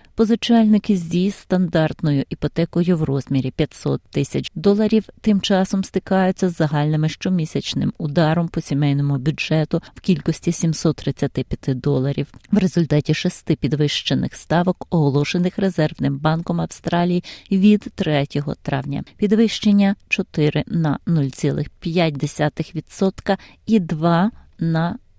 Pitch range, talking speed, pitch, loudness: 150-190 Hz, 100 wpm, 165 Hz, -20 LUFS